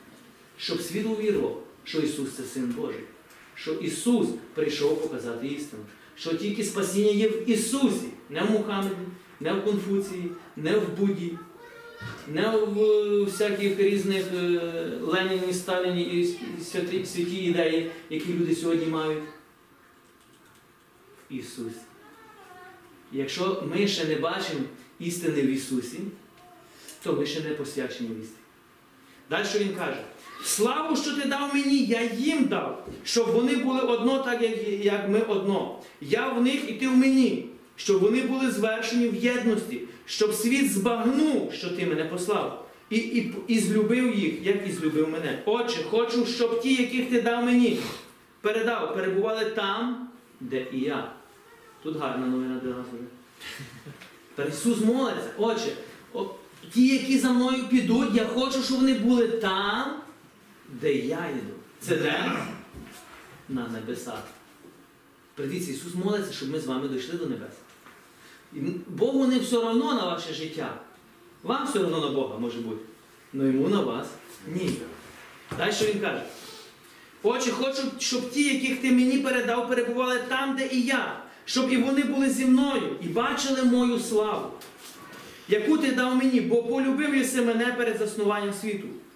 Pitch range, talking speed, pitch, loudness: 170-245 Hz, 145 wpm, 215 Hz, -26 LUFS